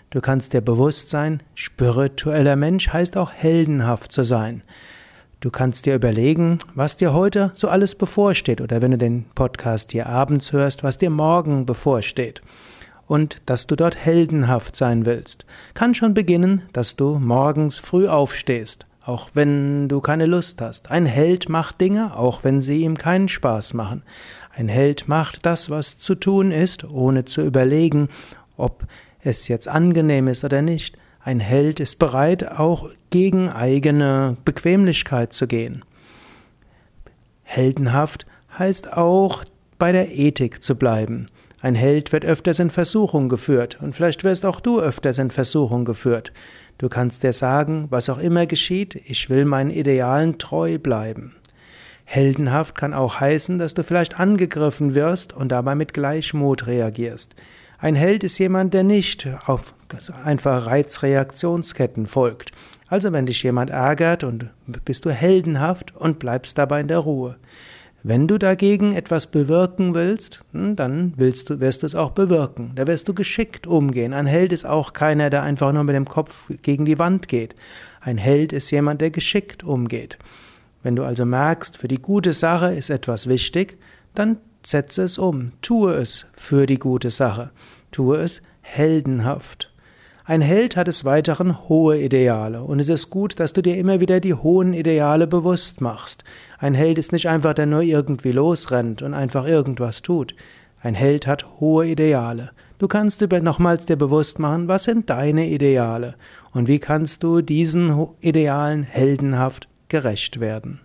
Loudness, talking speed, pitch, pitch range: -19 LUFS, 160 wpm, 145 Hz, 130-170 Hz